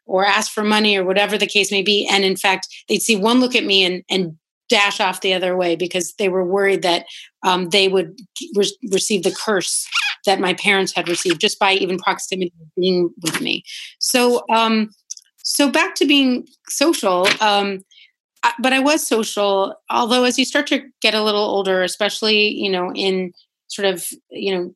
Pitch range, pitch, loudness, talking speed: 185-225 Hz, 200 Hz, -17 LUFS, 195 wpm